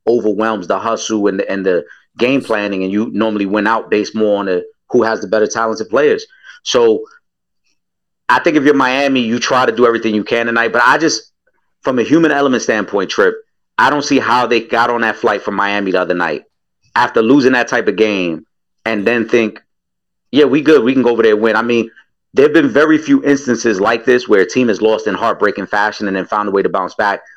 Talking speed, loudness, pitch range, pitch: 230 wpm, -14 LUFS, 105-140 Hz, 115 Hz